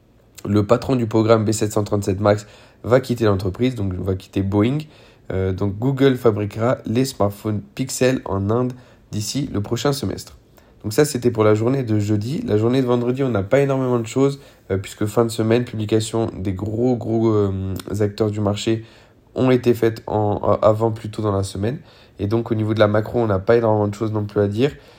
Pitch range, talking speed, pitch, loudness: 105-120 Hz, 200 wpm, 110 Hz, -20 LUFS